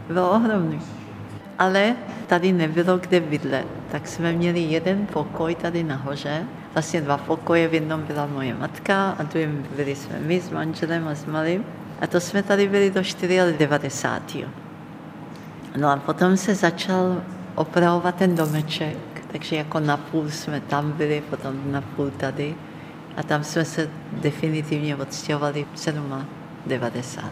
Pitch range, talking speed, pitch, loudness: 145-175 Hz, 145 wpm, 160 Hz, -23 LUFS